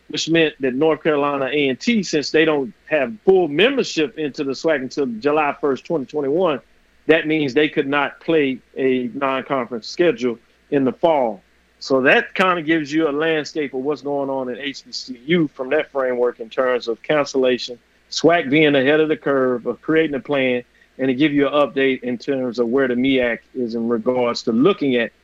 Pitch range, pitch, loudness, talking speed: 130-155 Hz, 140 Hz, -19 LUFS, 190 wpm